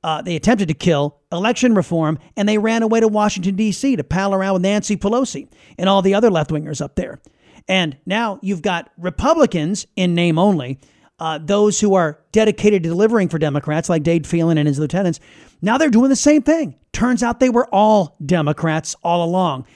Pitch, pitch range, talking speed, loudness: 190 Hz, 165-215 Hz, 195 wpm, -17 LUFS